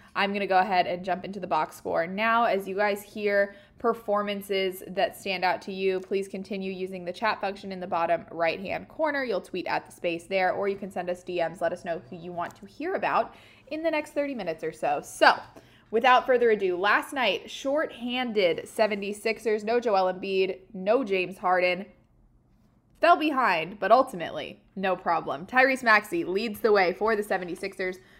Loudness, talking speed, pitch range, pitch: -27 LUFS, 190 wpm, 185-225 Hz, 195 Hz